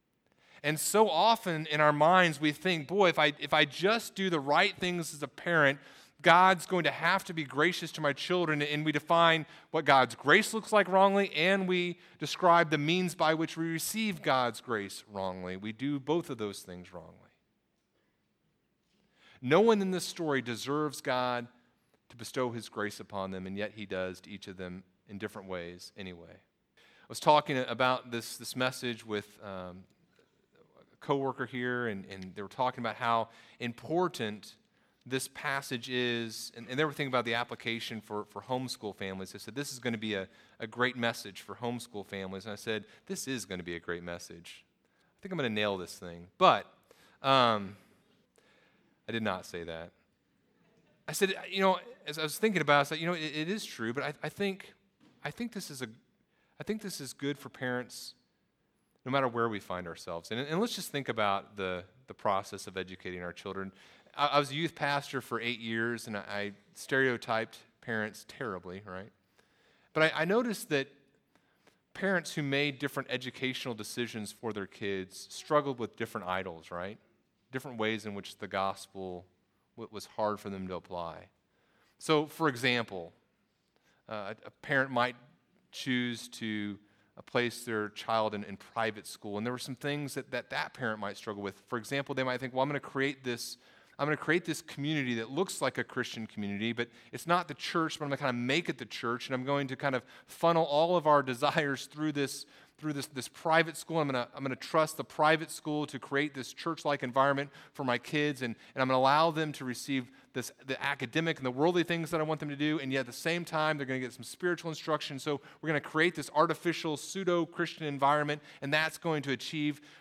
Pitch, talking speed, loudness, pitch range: 130 Hz, 205 wpm, -32 LUFS, 110-155 Hz